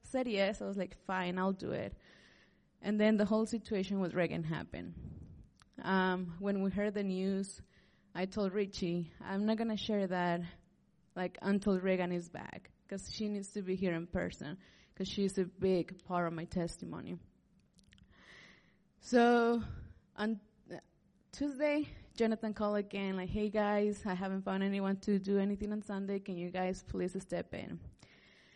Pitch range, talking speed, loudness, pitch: 185-210 Hz, 160 wpm, -36 LUFS, 195 Hz